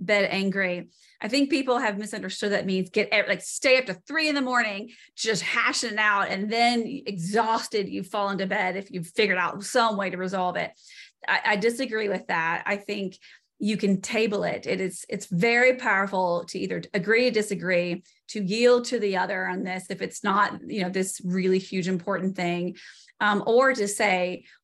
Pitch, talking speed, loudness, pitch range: 205 Hz, 195 wpm, -25 LUFS, 185-225 Hz